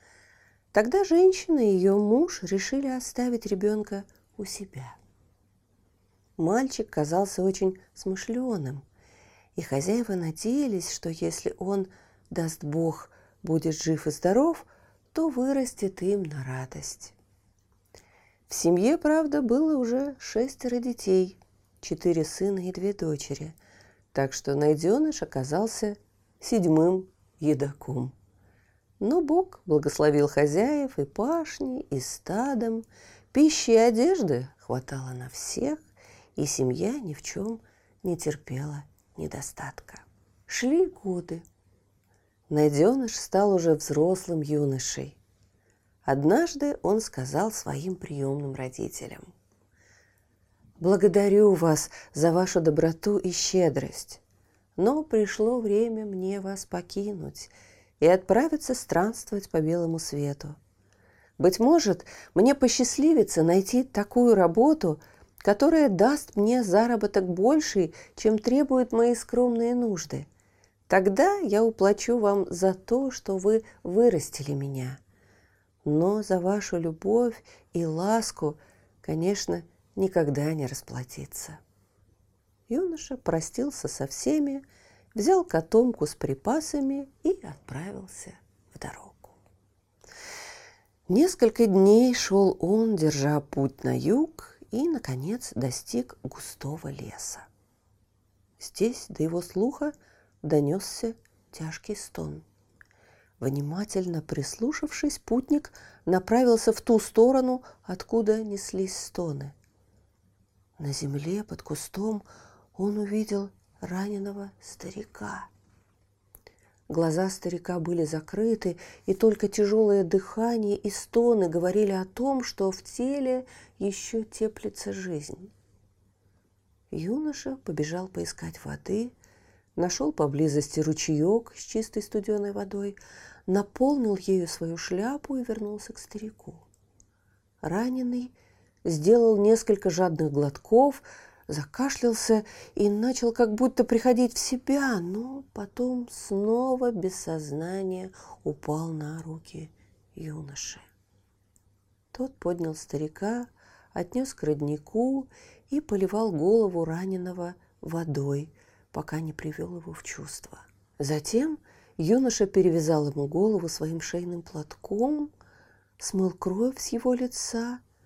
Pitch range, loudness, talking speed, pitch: 145-230 Hz, -26 LUFS, 100 wpm, 185 Hz